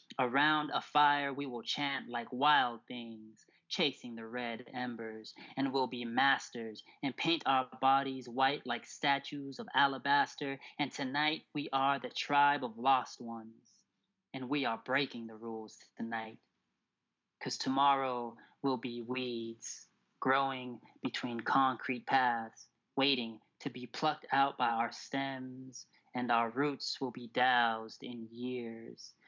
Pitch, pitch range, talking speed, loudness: 130 Hz, 115-140 Hz, 135 wpm, -34 LUFS